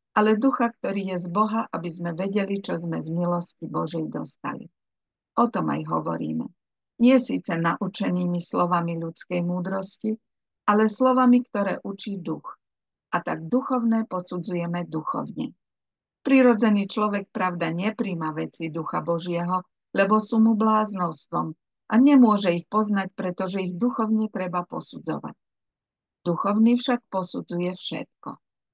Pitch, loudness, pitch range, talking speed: 190 Hz, -25 LUFS, 175-220 Hz, 125 wpm